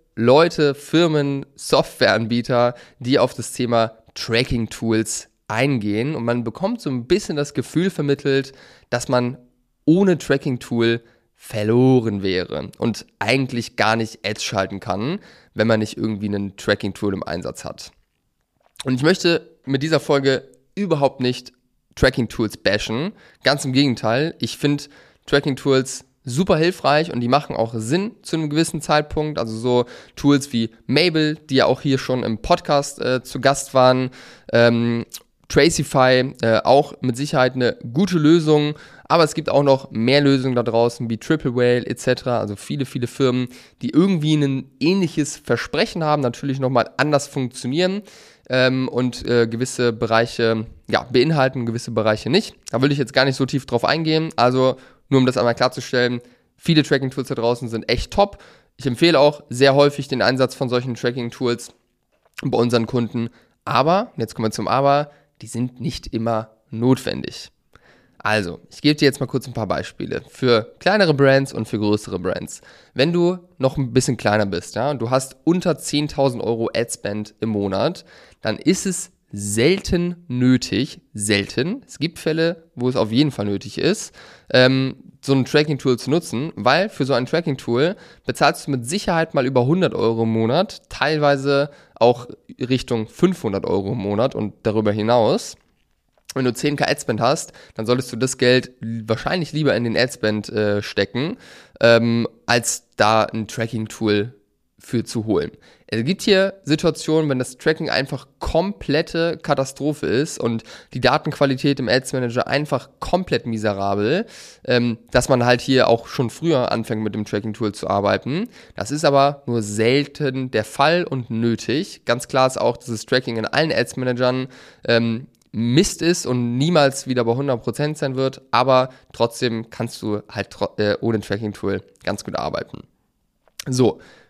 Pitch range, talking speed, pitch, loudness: 115-145 Hz, 165 wpm, 130 Hz, -20 LUFS